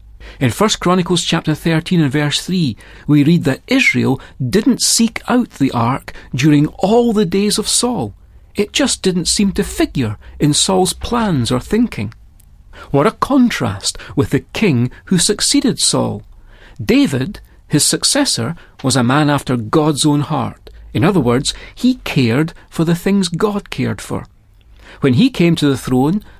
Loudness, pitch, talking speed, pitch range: -15 LUFS, 155 Hz, 160 wpm, 125-205 Hz